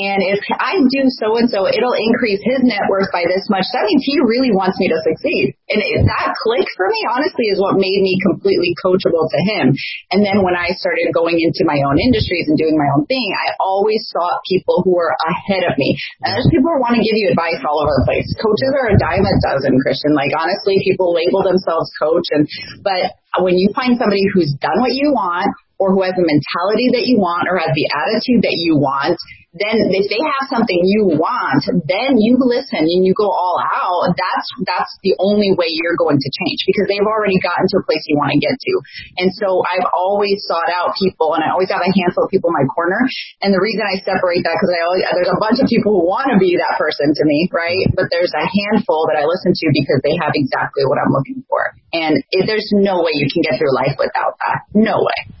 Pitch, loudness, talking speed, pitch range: 190 Hz, -15 LUFS, 235 wpm, 170-215 Hz